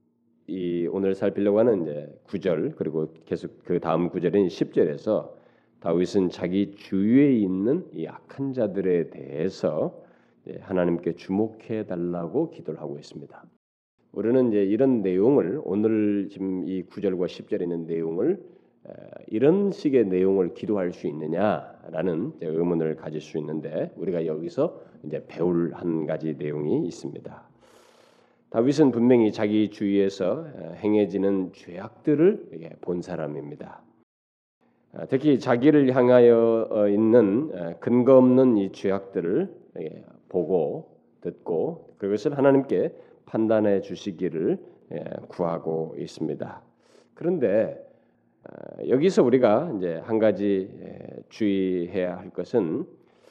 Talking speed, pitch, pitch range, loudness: 250 characters per minute, 95 Hz, 85-110 Hz, -24 LUFS